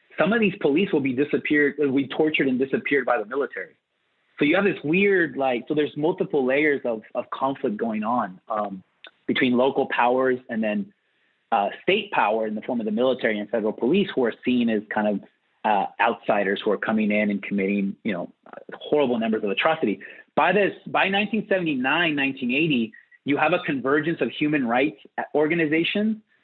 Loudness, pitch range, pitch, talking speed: -23 LUFS, 110-165 Hz, 135 Hz, 185 wpm